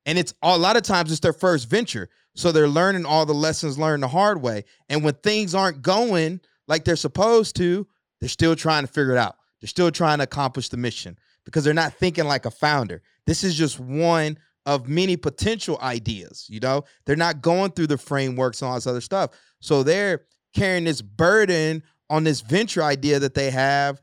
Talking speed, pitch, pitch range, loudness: 205 wpm, 155 Hz, 135-175 Hz, -22 LUFS